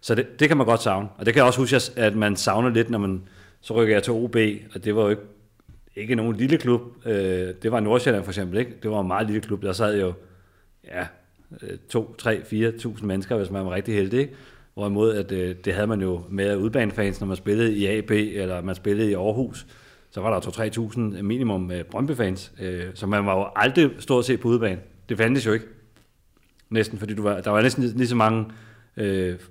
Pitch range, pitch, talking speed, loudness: 100-115 Hz, 105 Hz, 230 wpm, -23 LUFS